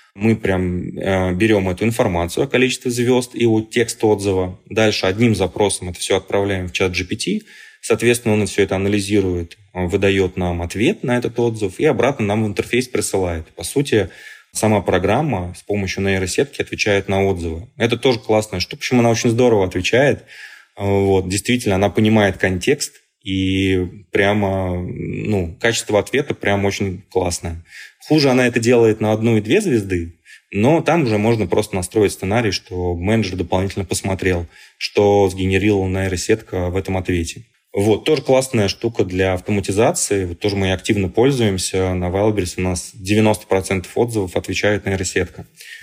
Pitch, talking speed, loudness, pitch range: 100 Hz, 150 wpm, -18 LUFS, 95-110 Hz